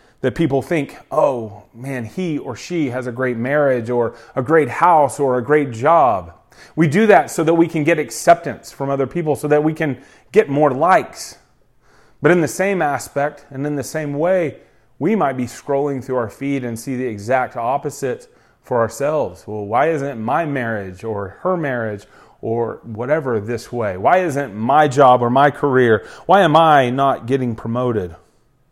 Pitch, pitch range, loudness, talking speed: 135 Hz, 120-150 Hz, -18 LUFS, 185 wpm